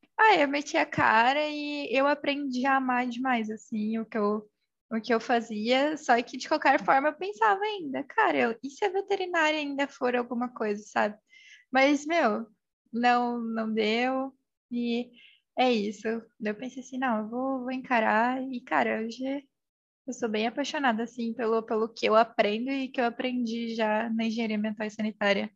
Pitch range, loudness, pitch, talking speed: 225-275 Hz, -28 LUFS, 245 Hz, 185 wpm